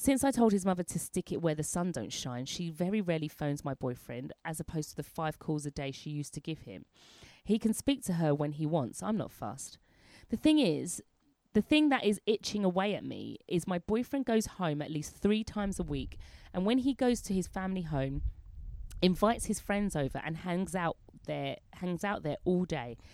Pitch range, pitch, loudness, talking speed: 145-205 Hz, 175 Hz, -33 LUFS, 225 wpm